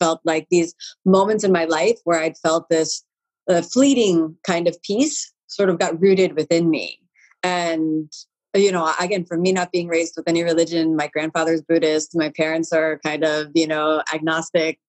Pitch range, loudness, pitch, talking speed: 160-180 Hz, -20 LUFS, 165 Hz, 180 wpm